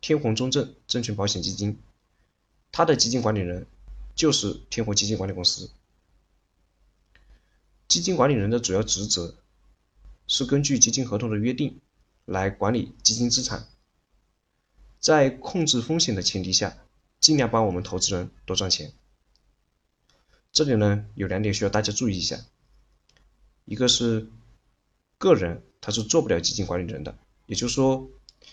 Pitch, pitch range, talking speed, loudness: 105 Hz, 90-120 Hz, 225 characters per minute, -23 LUFS